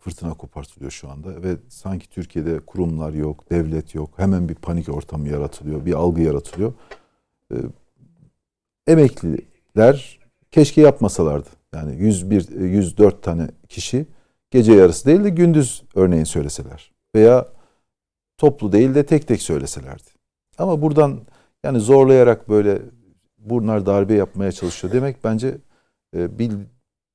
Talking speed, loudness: 120 wpm, -17 LUFS